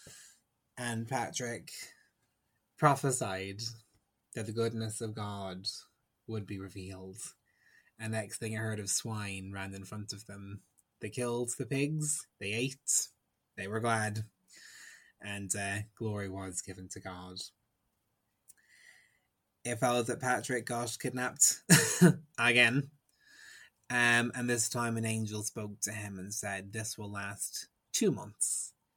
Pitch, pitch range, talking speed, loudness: 110 Hz, 100-120 Hz, 130 wpm, -33 LUFS